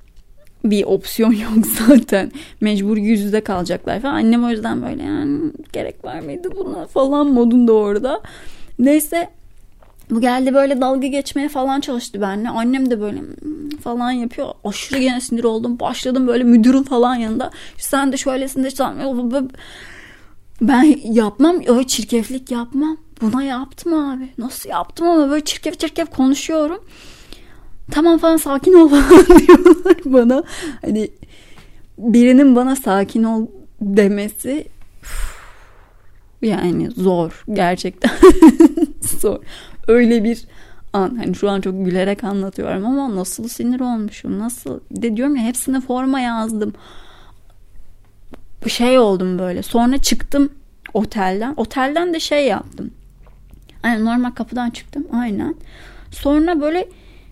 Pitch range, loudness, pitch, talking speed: 220-285 Hz, -16 LUFS, 250 Hz, 125 wpm